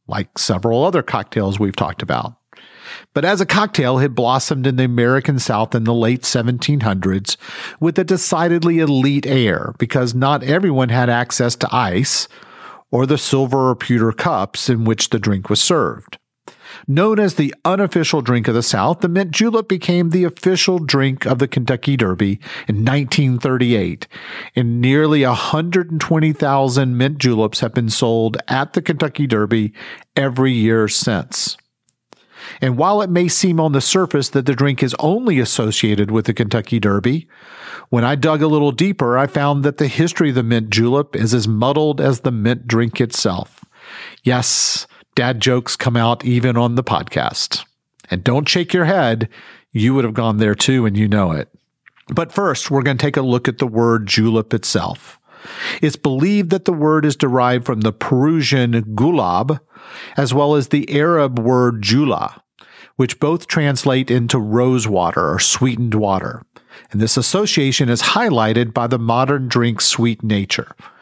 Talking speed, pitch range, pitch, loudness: 165 wpm, 115-150 Hz, 130 Hz, -16 LUFS